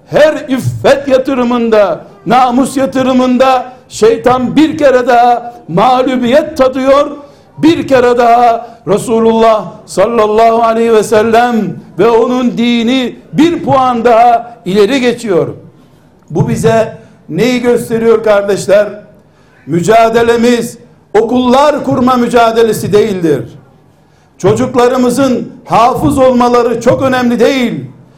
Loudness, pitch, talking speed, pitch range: -9 LUFS, 240 Hz, 90 wpm, 220-260 Hz